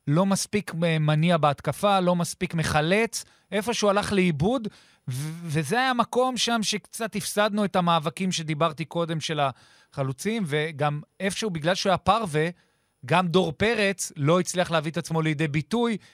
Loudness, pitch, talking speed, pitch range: -25 LUFS, 180 Hz, 150 wpm, 160-205 Hz